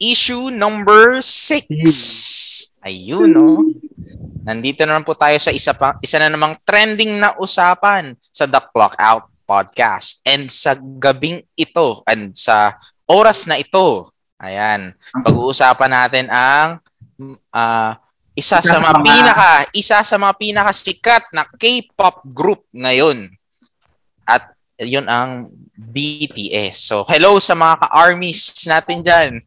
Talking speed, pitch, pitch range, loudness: 125 wpm, 155 Hz, 125-200 Hz, -12 LUFS